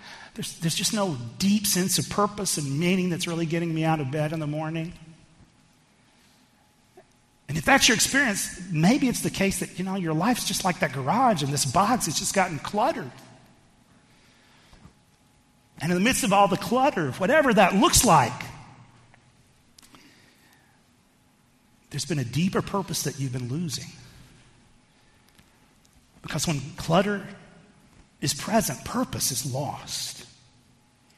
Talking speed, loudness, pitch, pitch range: 140 wpm, -24 LUFS, 165 Hz, 140-195 Hz